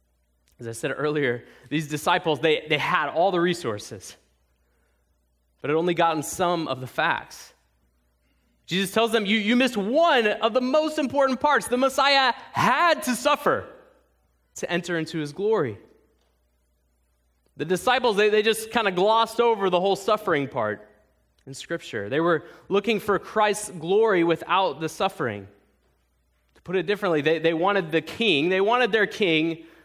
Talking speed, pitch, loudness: 160 wpm, 170 Hz, -23 LUFS